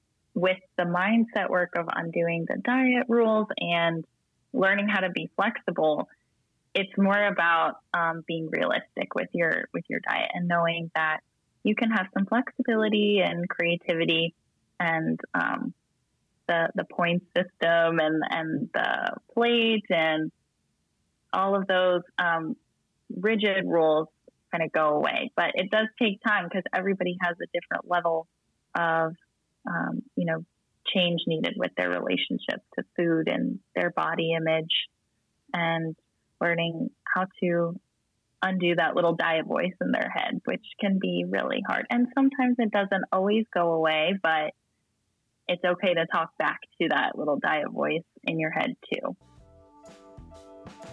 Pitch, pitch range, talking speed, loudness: 175 Hz, 160-200 Hz, 145 wpm, -26 LUFS